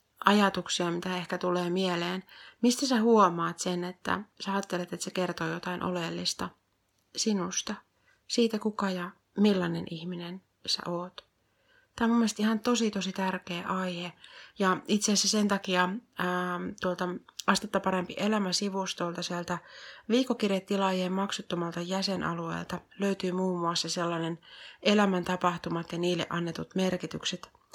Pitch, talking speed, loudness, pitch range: 185 Hz, 125 wpm, -30 LUFS, 175-200 Hz